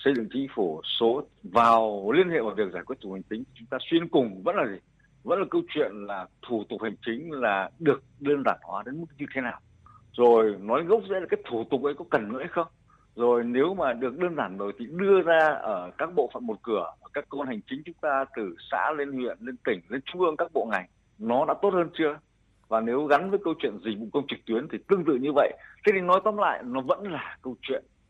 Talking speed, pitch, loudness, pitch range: 260 wpm, 135 Hz, -27 LUFS, 115-170 Hz